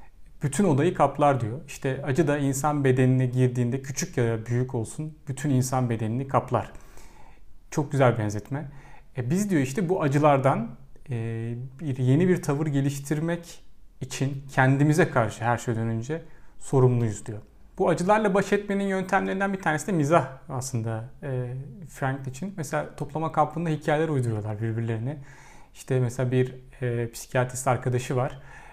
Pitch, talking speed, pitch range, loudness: 135 Hz, 140 wpm, 125-155 Hz, -26 LUFS